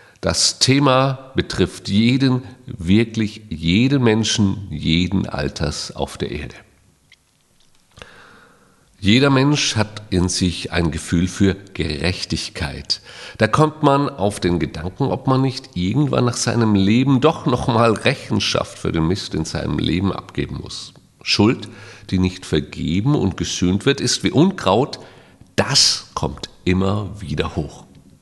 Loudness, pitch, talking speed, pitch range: -19 LUFS, 105 Hz, 130 wpm, 90-125 Hz